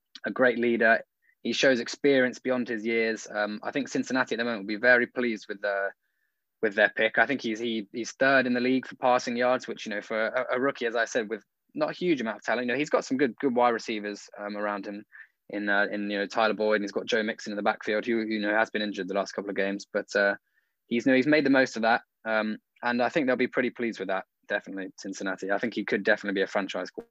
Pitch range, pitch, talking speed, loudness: 105-125 Hz, 115 Hz, 270 wpm, -27 LUFS